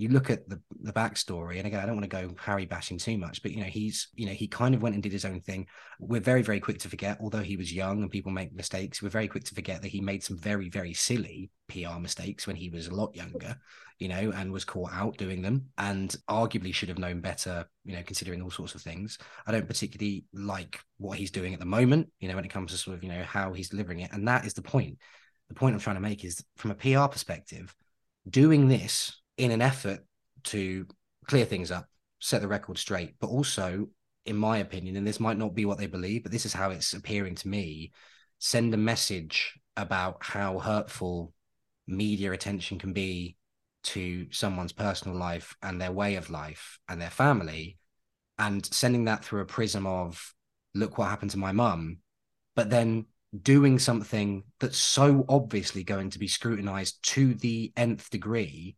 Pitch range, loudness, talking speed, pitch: 95-110 Hz, -30 LUFS, 215 wpm, 100 Hz